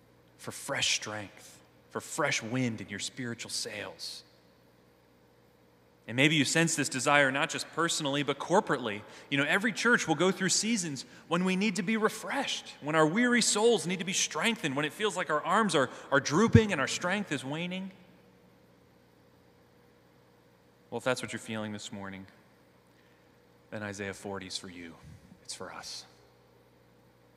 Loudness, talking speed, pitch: -29 LUFS, 160 wpm, 110 Hz